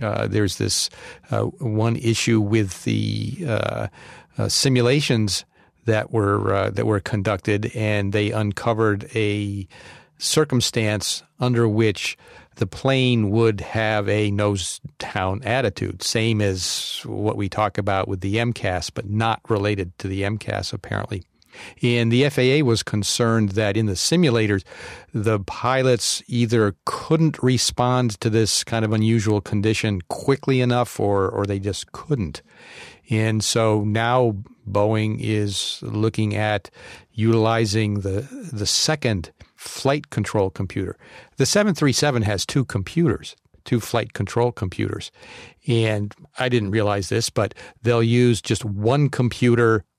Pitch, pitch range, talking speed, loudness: 110 Hz, 105-120 Hz, 130 wpm, -21 LUFS